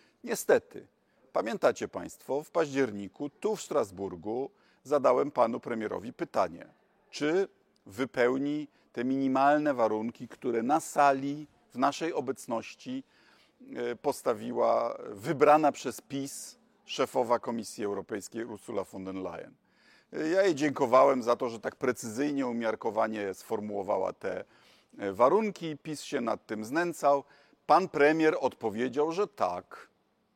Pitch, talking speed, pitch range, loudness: 135 Hz, 110 wpm, 115-150 Hz, -30 LUFS